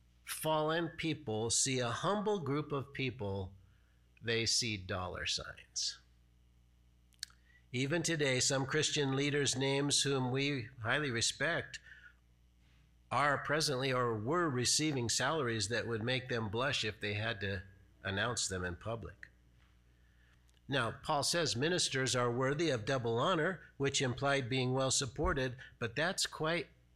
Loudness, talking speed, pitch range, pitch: -34 LUFS, 130 wpm, 95-140 Hz, 120 Hz